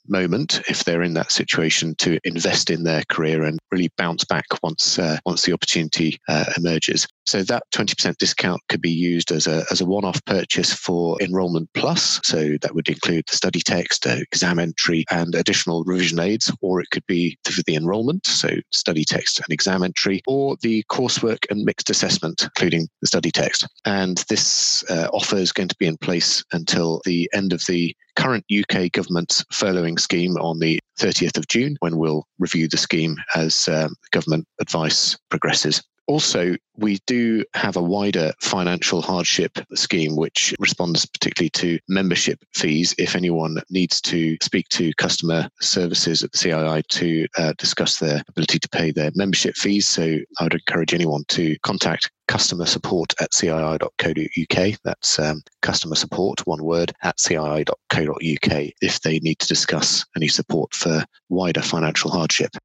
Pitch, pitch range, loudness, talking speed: 85 Hz, 80-90 Hz, -20 LUFS, 165 wpm